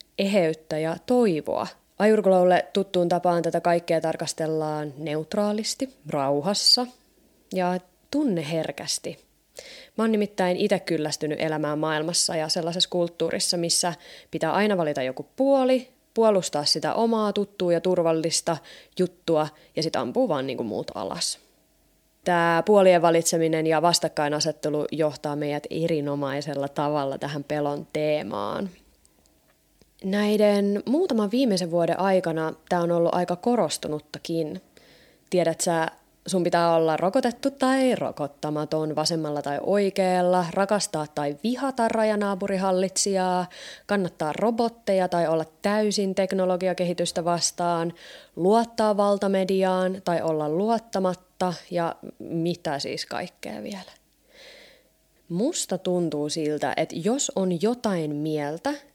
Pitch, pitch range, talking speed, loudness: 175 Hz, 155-200 Hz, 105 wpm, -24 LUFS